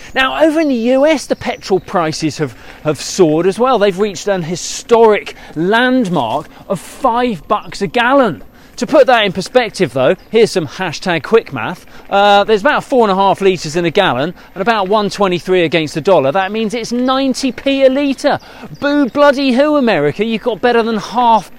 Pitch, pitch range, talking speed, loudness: 220 Hz, 185-255 Hz, 185 wpm, -13 LUFS